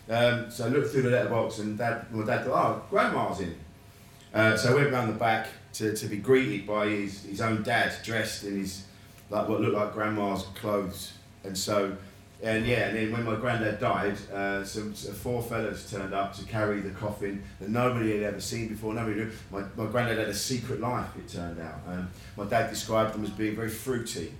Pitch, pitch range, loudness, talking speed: 105 Hz, 100-115 Hz, -29 LUFS, 215 wpm